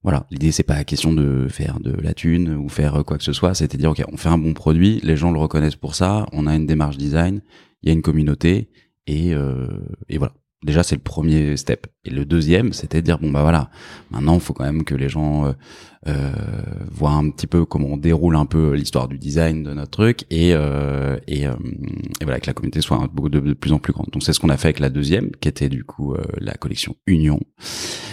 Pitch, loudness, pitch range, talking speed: 75 Hz, -20 LUFS, 70-85 Hz, 250 wpm